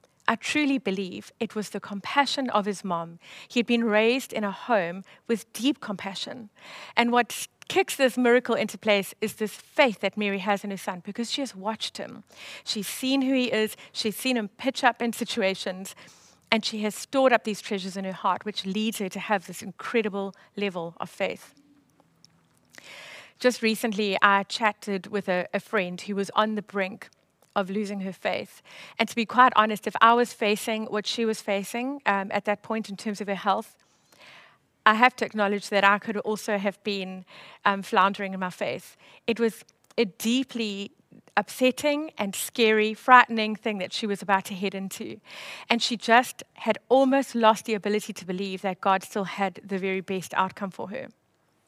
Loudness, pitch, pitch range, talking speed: -26 LUFS, 210 Hz, 195-230 Hz, 190 wpm